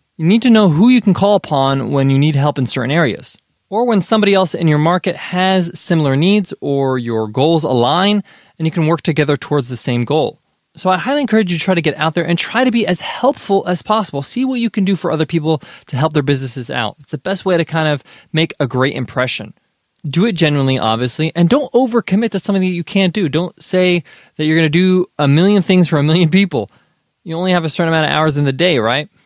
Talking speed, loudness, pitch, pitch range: 250 wpm, -15 LUFS, 170 Hz, 145-195 Hz